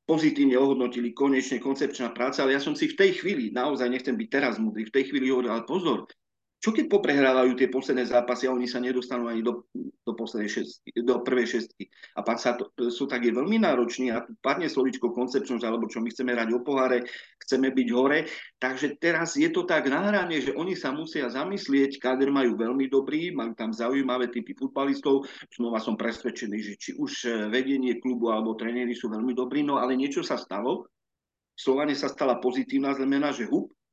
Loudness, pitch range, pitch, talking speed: -27 LUFS, 120-140 Hz, 130 Hz, 190 wpm